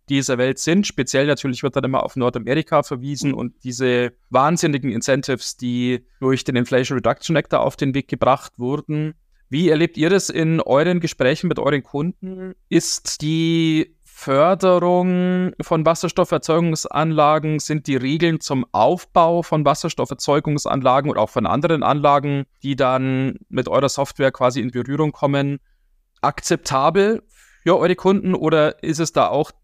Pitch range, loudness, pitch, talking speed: 130-165 Hz, -19 LUFS, 145 Hz, 145 wpm